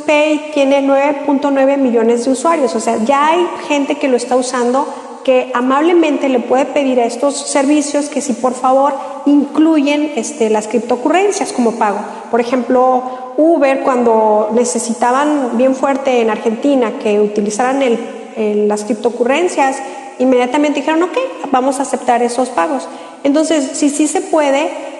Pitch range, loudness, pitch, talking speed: 245-290 Hz, -14 LUFS, 270 Hz, 150 wpm